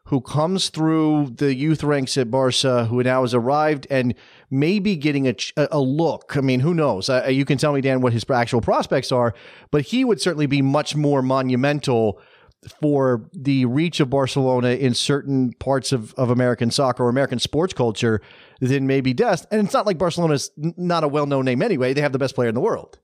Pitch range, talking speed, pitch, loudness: 125-150 Hz, 215 wpm, 135 Hz, -20 LUFS